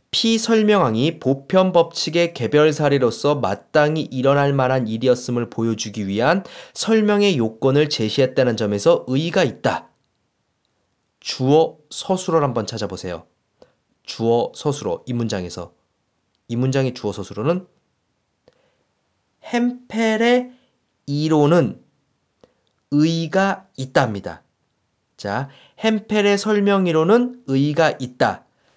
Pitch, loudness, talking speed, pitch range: 145 Hz, -19 LUFS, 240 characters per minute, 120-190 Hz